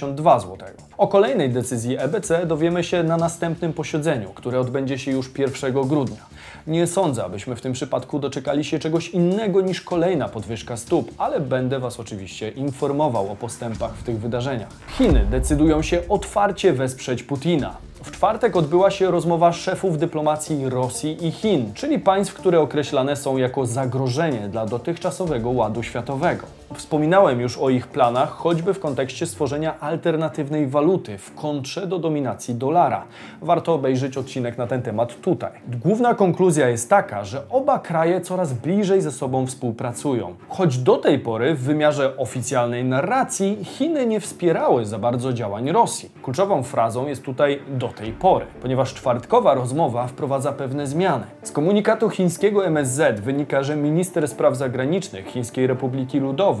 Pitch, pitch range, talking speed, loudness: 145 Hz, 125-170 Hz, 150 wpm, -21 LUFS